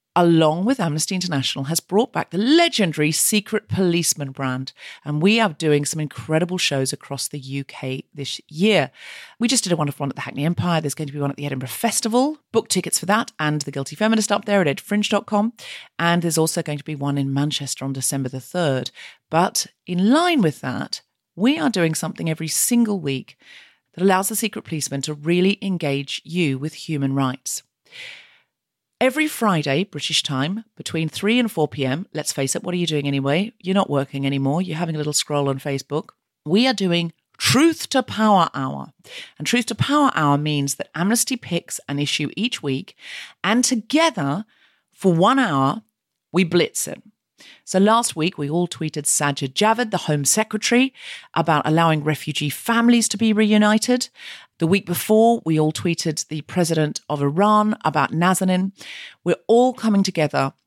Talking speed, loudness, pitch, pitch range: 180 wpm, -20 LUFS, 170 Hz, 145-215 Hz